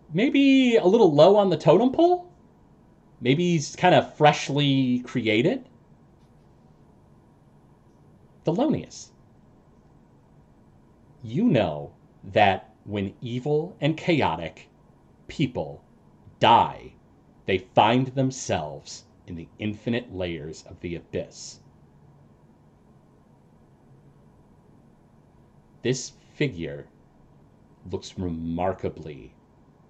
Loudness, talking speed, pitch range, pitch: -23 LUFS, 75 wpm, 95-155 Hz, 125 Hz